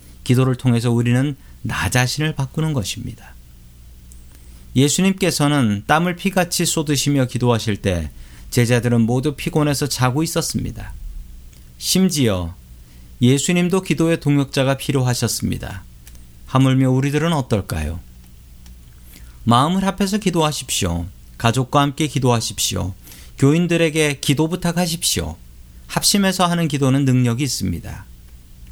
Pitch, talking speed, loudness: 125 Hz, 295 characters per minute, -18 LUFS